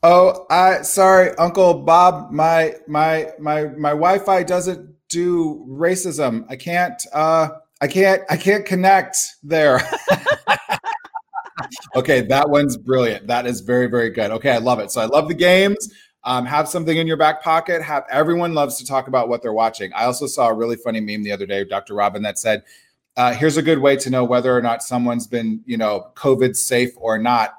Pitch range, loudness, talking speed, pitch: 125-180 Hz, -18 LUFS, 190 wpm, 155 Hz